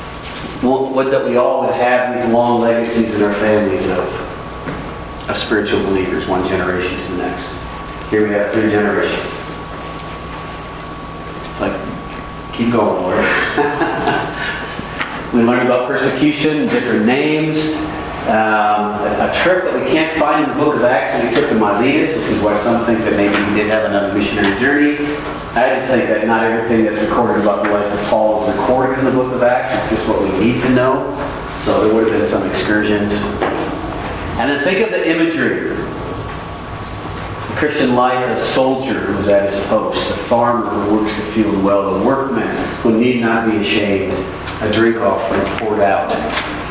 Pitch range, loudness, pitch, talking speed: 100-125 Hz, -15 LUFS, 110 Hz, 175 wpm